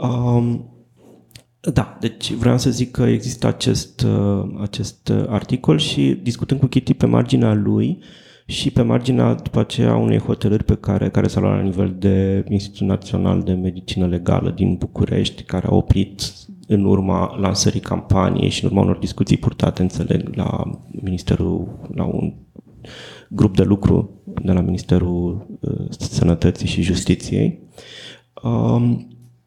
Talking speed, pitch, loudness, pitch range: 140 wpm, 100 Hz, -19 LUFS, 90-110 Hz